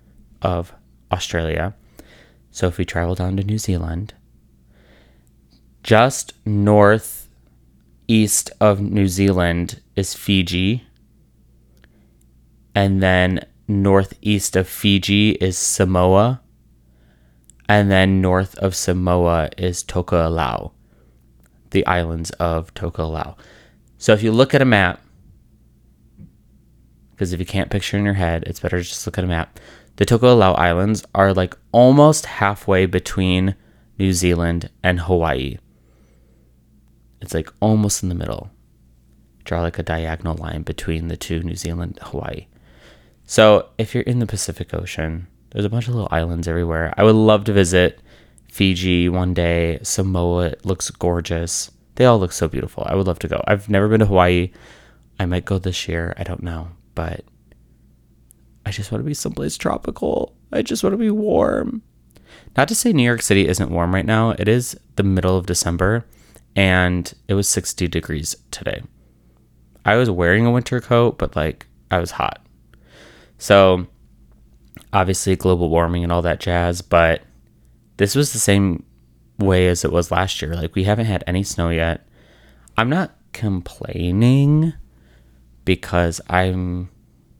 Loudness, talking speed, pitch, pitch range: -18 LUFS, 145 wpm, 90 Hz, 80-100 Hz